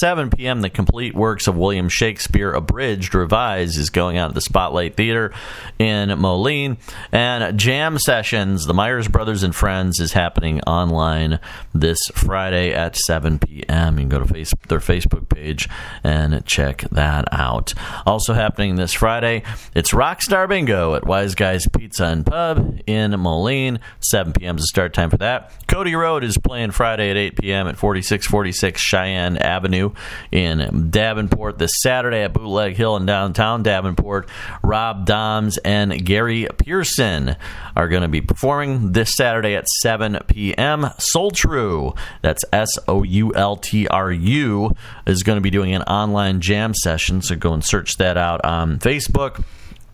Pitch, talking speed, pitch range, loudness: 100 Hz, 165 wpm, 90-110 Hz, -18 LUFS